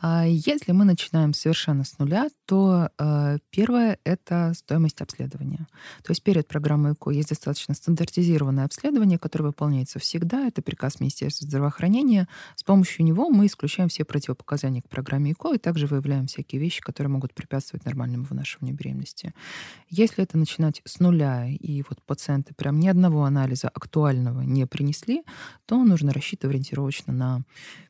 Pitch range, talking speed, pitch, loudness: 140-175 Hz, 150 wpm, 150 Hz, -24 LUFS